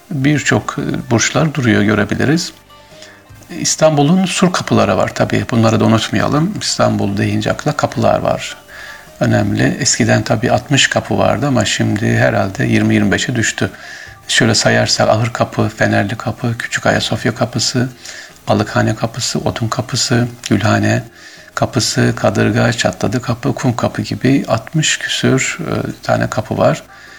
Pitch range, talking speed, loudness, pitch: 105-130 Hz, 120 wpm, -14 LUFS, 115 Hz